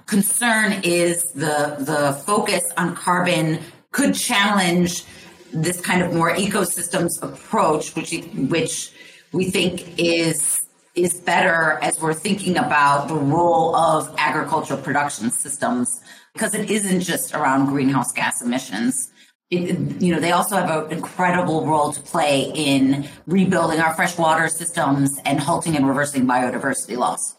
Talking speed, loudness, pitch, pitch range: 135 wpm, -20 LUFS, 165 Hz, 150-180 Hz